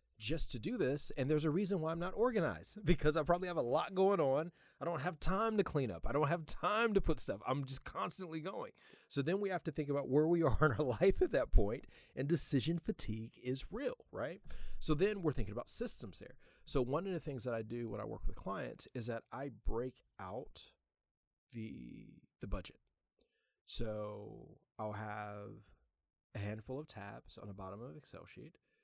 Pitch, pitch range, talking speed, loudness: 140 Hz, 115-170 Hz, 210 wpm, -38 LUFS